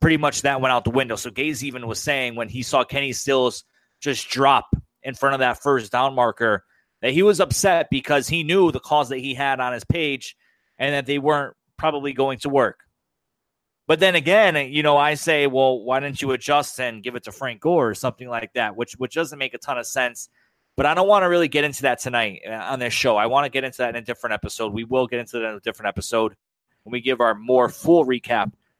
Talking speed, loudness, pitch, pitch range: 245 wpm, -21 LUFS, 135 Hz, 125-145 Hz